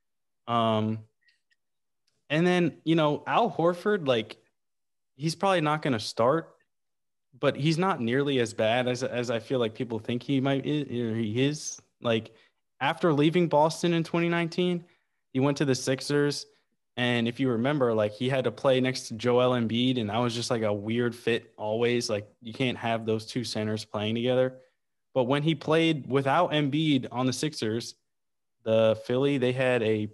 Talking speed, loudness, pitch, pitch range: 175 wpm, -27 LUFS, 130 Hz, 115-150 Hz